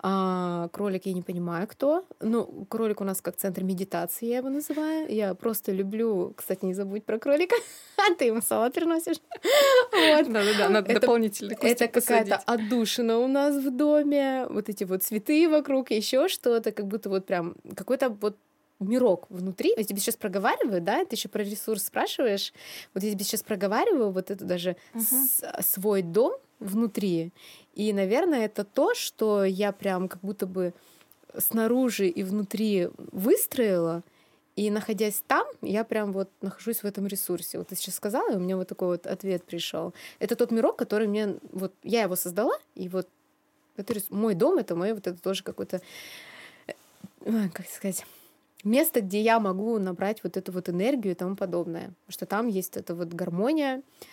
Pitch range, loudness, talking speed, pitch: 190-235 Hz, -27 LUFS, 165 wpm, 210 Hz